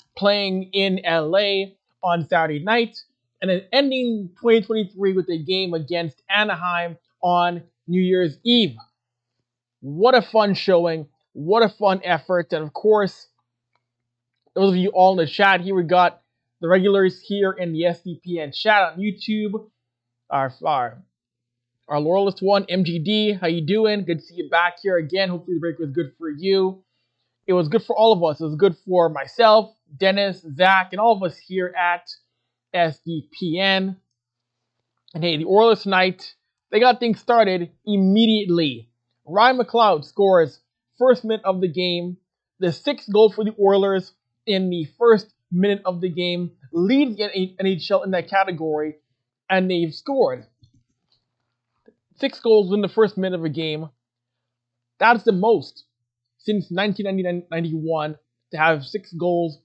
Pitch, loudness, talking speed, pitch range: 180 Hz, -20 LUFS, 155 wpm, 155-200 Hz